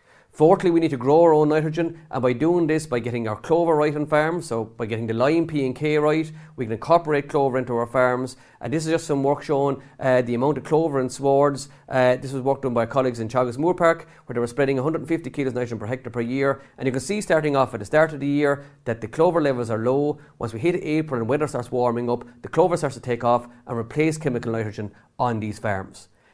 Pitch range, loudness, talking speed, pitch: 120-155 Hz, -22 LUFS, 255 wpm, 135 Hz